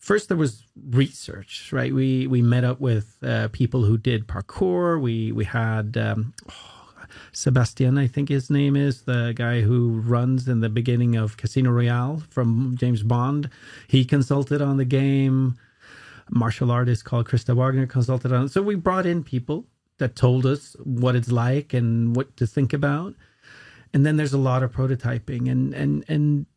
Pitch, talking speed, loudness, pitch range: 125 Hz, 180 wpm, -22 LUFS, 120-140 Hz